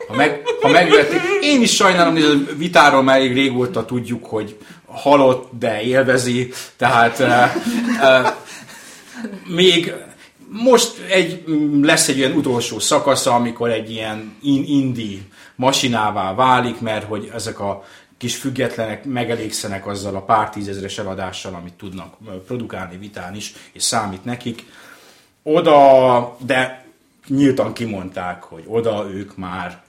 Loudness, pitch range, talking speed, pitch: -16 LUFS, 105-140 Hz, 120 wpm, 120 Hz